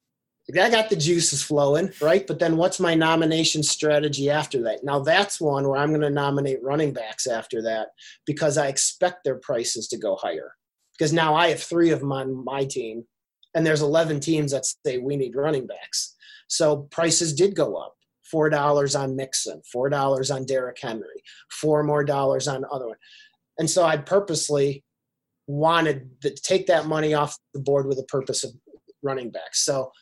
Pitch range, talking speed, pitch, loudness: 140-165 Hz, 190 wpm, 150 Hz, -23 LUFS